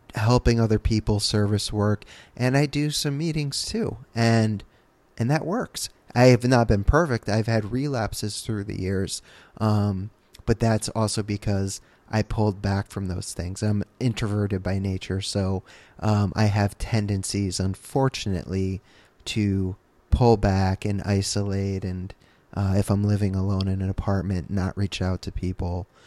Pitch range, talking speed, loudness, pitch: 95-110 Hz, 150 wpm, -25 LUFS, 105 Hz